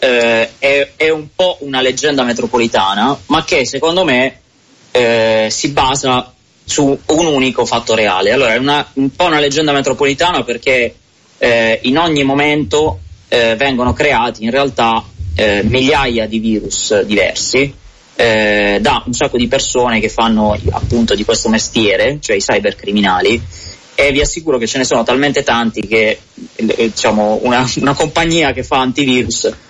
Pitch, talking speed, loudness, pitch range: 125 Hz, 155 wpm, -13 LUFS, 110-140 Hz